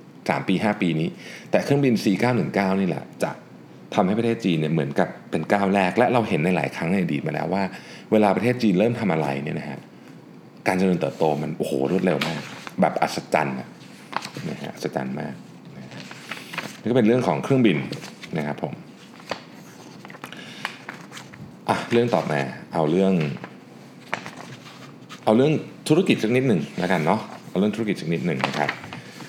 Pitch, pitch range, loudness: 95 Hz, 80-110 Hz, -23 LUFS